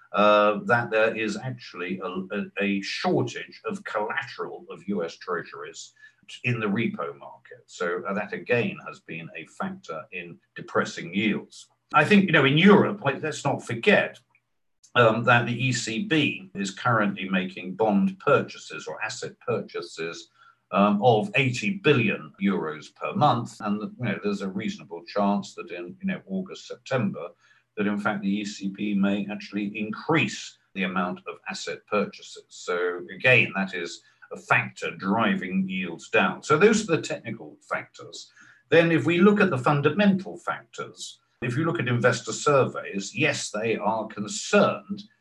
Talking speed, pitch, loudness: 155 wpm, 130 Hz, -25 LUFS